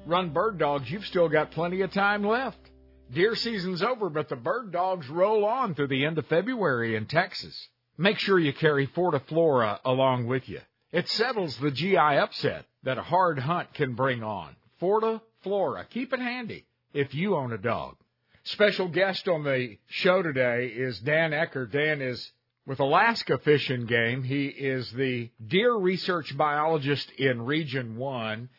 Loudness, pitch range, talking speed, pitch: -27 LUFS, 130-185 Hz, 170 wpm, 150 Hz